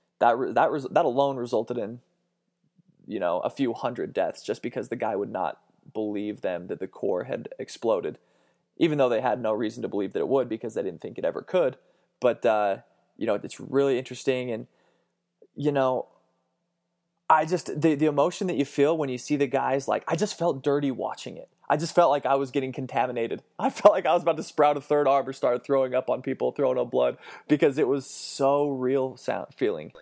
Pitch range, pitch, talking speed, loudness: 130-165 Hz, 140 Hz, 220 wpm, -26 LUFS